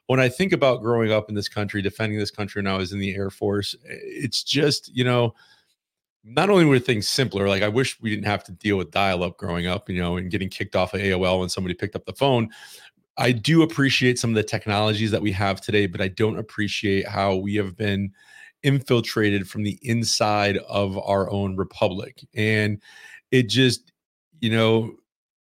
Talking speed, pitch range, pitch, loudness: 205 wpm, 100-120 Hz, 105 Hz, -23 LUFS